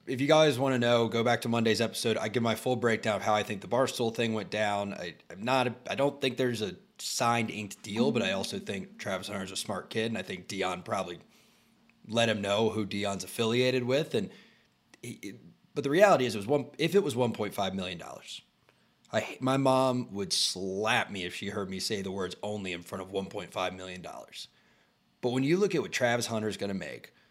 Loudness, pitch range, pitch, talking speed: -30 LUFS, 100-130 Hz, 115 Hz, 225 wpm